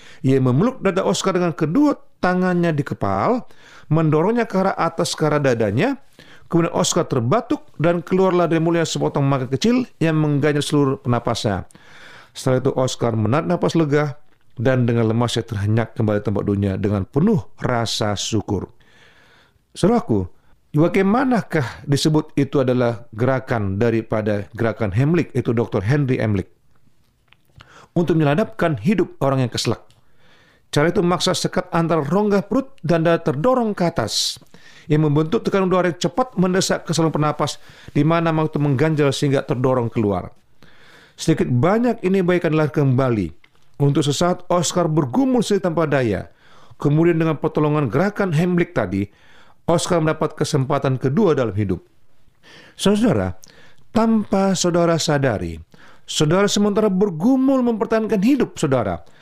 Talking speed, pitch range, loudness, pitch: 135 wpm, 125-180 Hz, -19 LUFS, 155 Hz